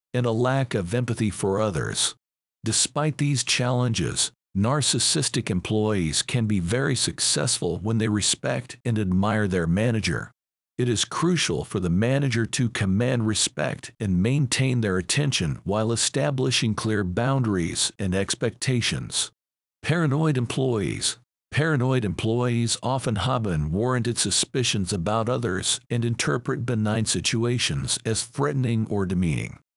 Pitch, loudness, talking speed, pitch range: 115 Hz, -24 LUFS, 120 wpm, 105-130 Hz